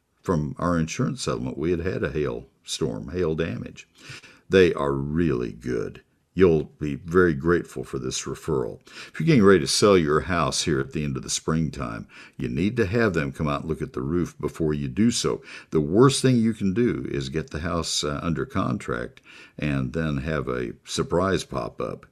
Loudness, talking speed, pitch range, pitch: -24 LUFS, 200 wpm, 70-85 Hz, 80 Hz